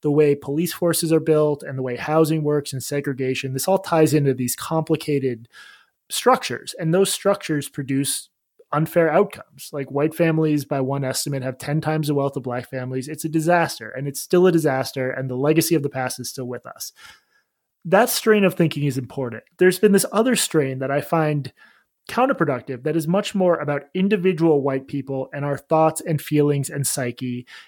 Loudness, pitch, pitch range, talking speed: -21 LUFS, 150 Hz, 135-165 Hz, 190 wpm